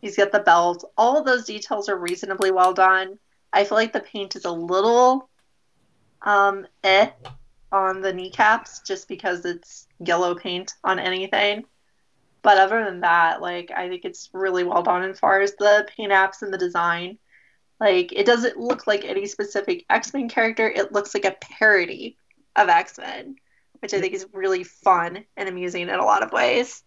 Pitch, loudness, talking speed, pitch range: 200 Hz, -21 LUFS, 180 wpm, 185-225 Hz